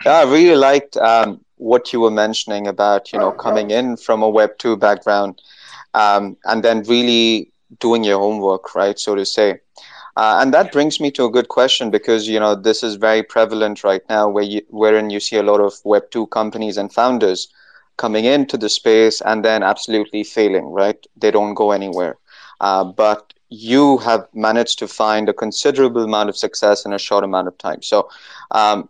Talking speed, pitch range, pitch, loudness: 195 wpm, 105-115 Hz, 110 Hz, -16 LUFS